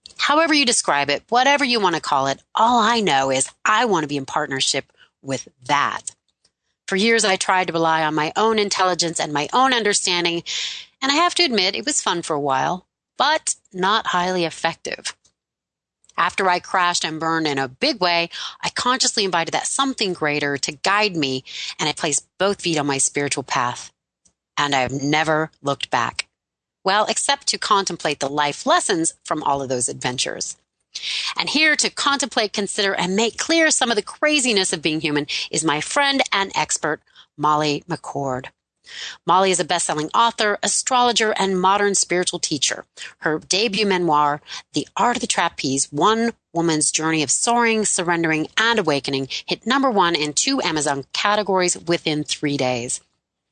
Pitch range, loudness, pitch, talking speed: 150-220 Hz, -19 LUFS, 175 Hz, 175 wpm